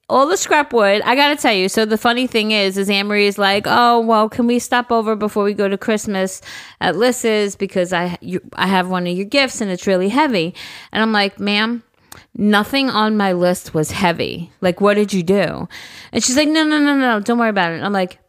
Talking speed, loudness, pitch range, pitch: 235 wpm, -16 LUFS, 190-235 Hz, 210 Hz